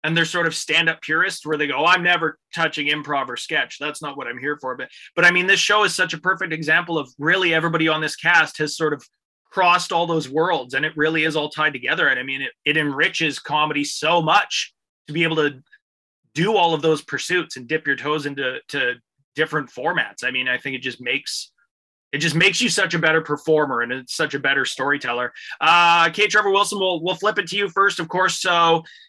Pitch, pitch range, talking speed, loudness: 160 Hz, 150-175 Hz, 235 wpm, -19 LUFS